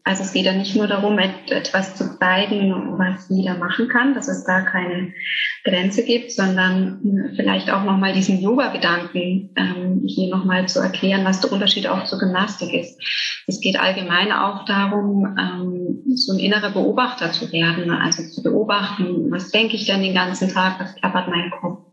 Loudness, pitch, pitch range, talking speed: -19 LUFS, 190 Hz, 185-205 Hz, 175 wpm